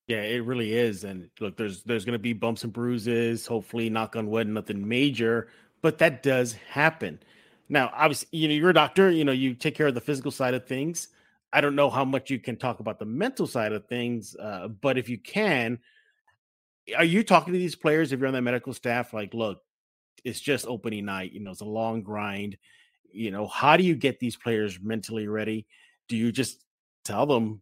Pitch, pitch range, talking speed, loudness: 120 Hz, 110-145 Hz, 215 wpm, -26 LUFS